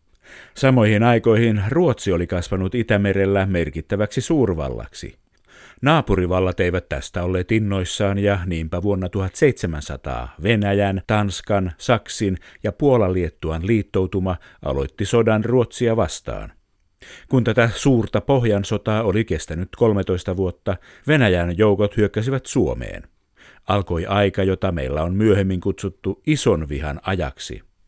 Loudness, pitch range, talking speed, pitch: -20 LUFS, 90-110 Hz, 105 wpm, 100 Hz